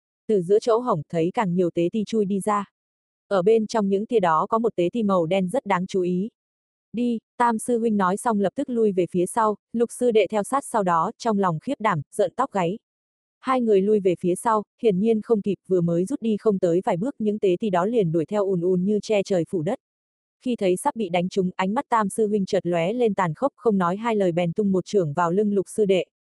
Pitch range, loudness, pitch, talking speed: 180-225 Hz, -23 LUFS, 205 Hz, 260 wpm